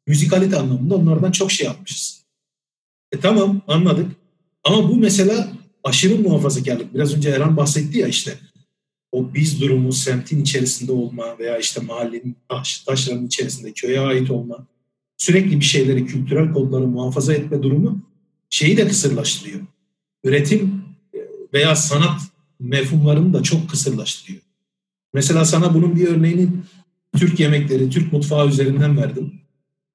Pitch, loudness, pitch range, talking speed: 150 Hz, -18 LUFS, 135-185 Hz, 130 wpm